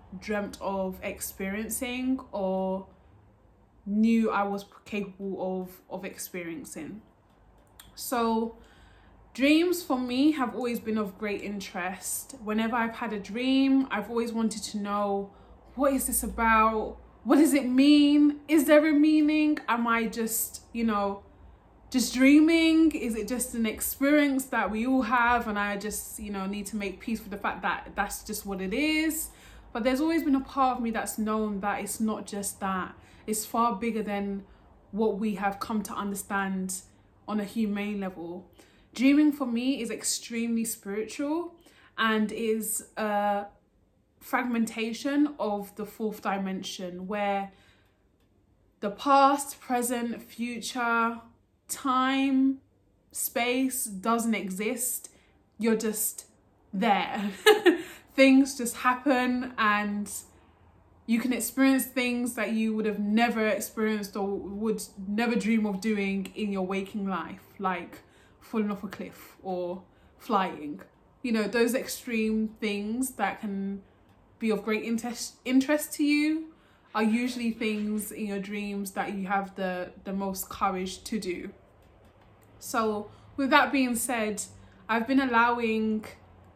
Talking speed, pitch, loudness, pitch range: 140 wpm, 220 Hz, -28 LUFS, 200-250 Hz